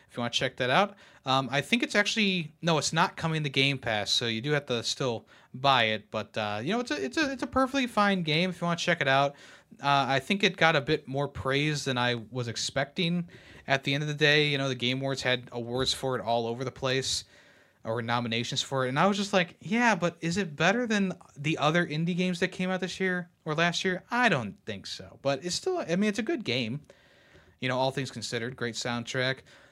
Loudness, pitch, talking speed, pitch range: -28 LUFS, 145 Hz, 255 wpm, 125-180 Hz